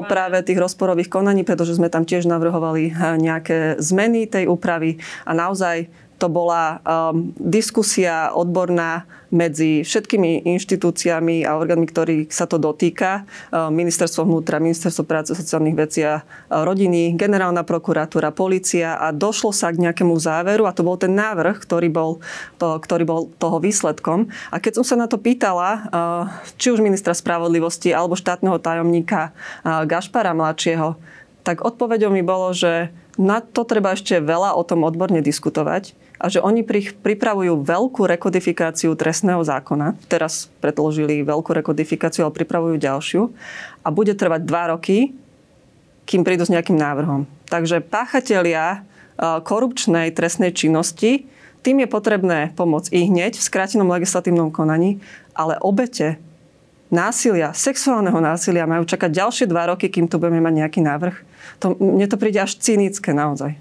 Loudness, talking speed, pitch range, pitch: -19 LUFS, 145 wpm, 165-195 Hz, 170 Hz